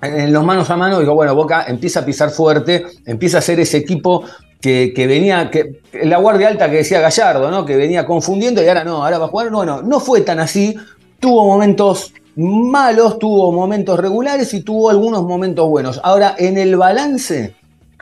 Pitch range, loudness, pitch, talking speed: 155-205 Hz, -13 LUFS, 180 Hz, 195 wpm